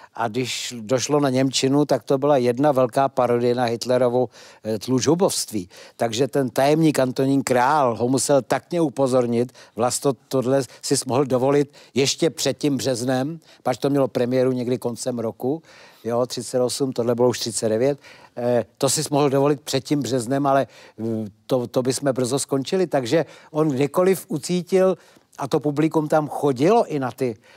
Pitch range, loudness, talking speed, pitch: 125-145 Hz, -21 LUFS, 160 wpm, 135 Hz